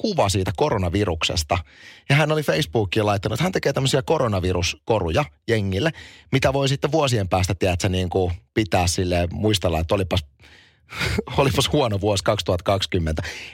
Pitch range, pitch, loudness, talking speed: 90-115 Hz, 100 Hz, -22 LUFS, 135 wpm